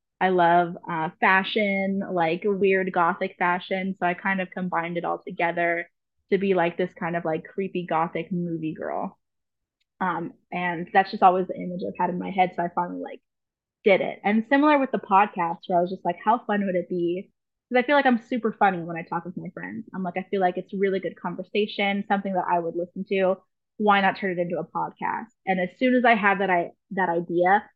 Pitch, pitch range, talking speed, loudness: 185 Hz, 175-200 Hz, 225 wpm, -24 LUFS